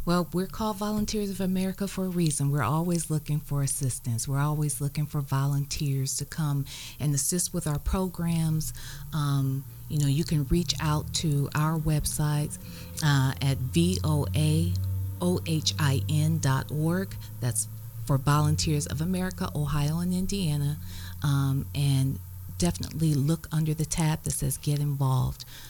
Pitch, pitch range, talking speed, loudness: 145 Hz, 130-155 Hz, 135 wpm, -28 LUFS